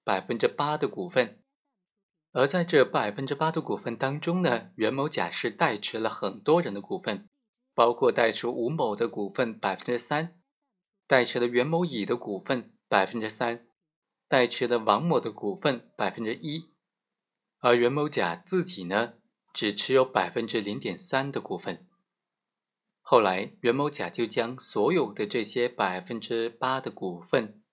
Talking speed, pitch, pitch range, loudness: 235 characters per minute, 135 Hz, 120-175 Hz, -27 LUFS